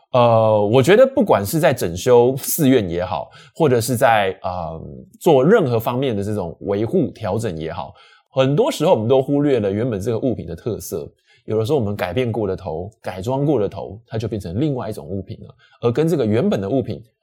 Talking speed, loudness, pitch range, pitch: 310 characters per minute, -18 LUFS, 105-135 Hz, 115 Hz